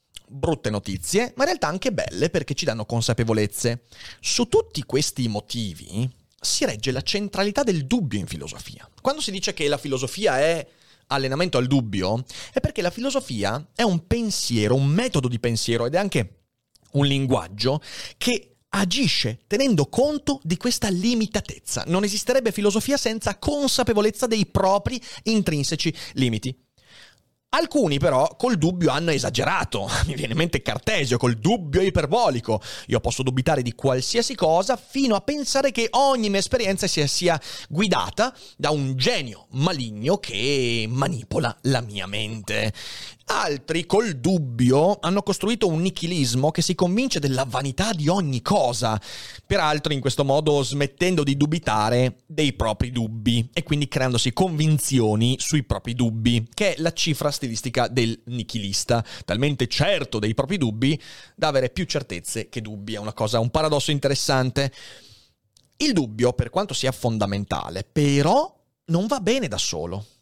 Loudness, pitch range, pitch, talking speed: -23 LUFS, 120-185 Hz, 140 Hz, 145 wpm